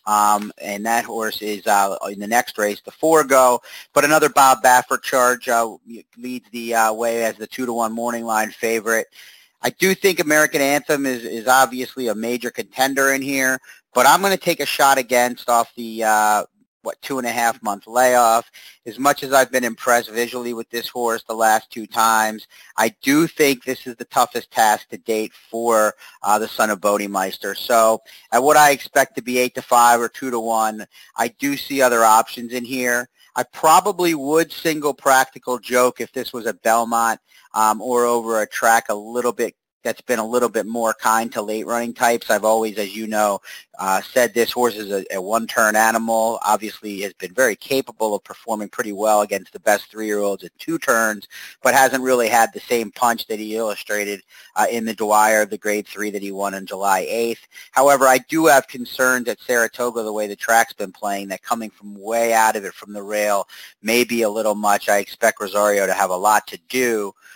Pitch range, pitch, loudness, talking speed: 110-125 Hz, 115 Hz, -19 LUFS, 210 wpm